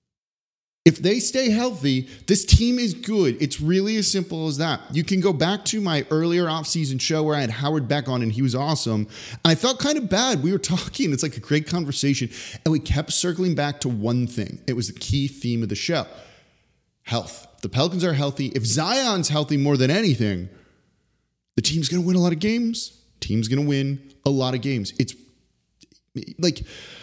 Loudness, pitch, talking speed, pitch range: -22 LUFS, 150 Hz, 200 wpm, 130-180 Hz